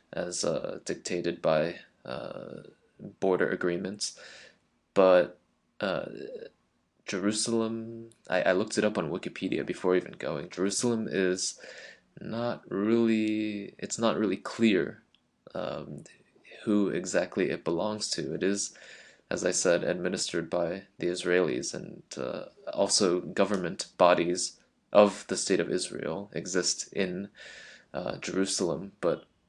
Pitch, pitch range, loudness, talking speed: 95 Hz, 90-110 Hz, -29 LUFS, 115 wpm